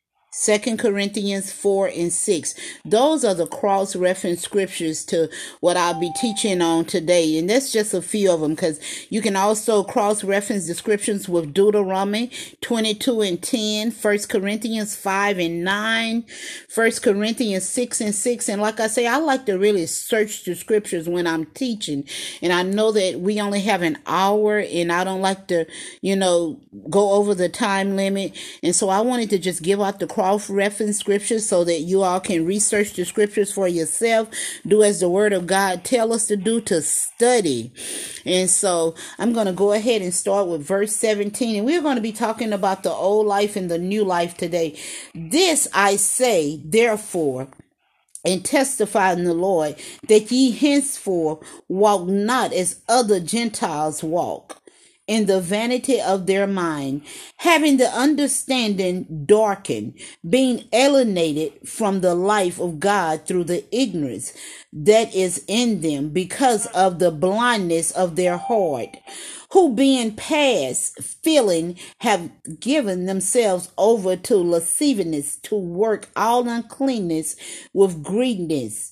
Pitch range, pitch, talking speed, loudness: 180-225 Hz, 200 Hz, 155 wpm, -20 LUFS